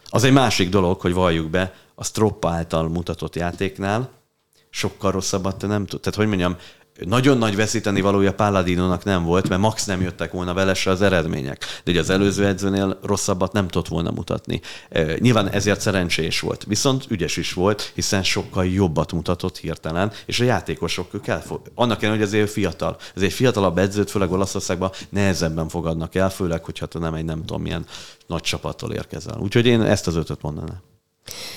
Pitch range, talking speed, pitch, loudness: 90-105 Hz, 175 wpm, 95 Hz, -21 LUFS